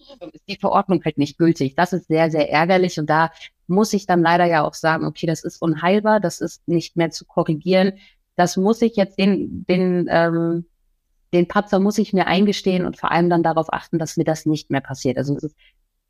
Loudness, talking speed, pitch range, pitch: -19 LUFS, 215 wpm, 160-190 Hz, 170 Hz